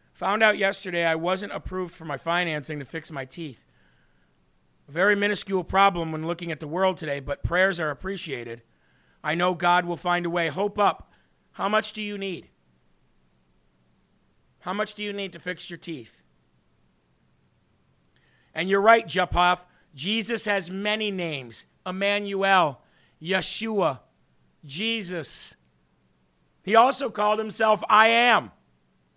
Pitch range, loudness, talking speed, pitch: 140-200 Hz, -24 LUFS, 140 wpm, 175 Hz